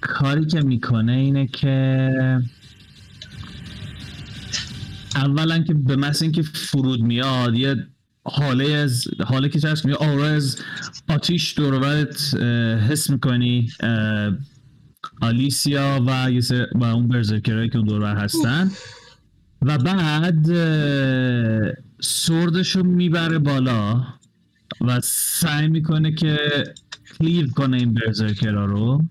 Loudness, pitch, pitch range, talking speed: -20 LUFS, 135 Hz, 120-150 Hz, 100 wpm